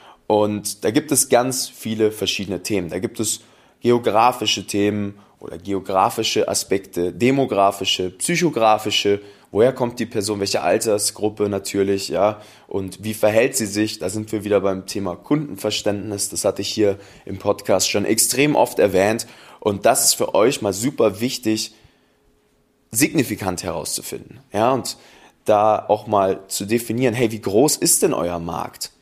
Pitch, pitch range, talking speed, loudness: 105 Hz, 100-110 Hz, 150 wpm, -20 LUFS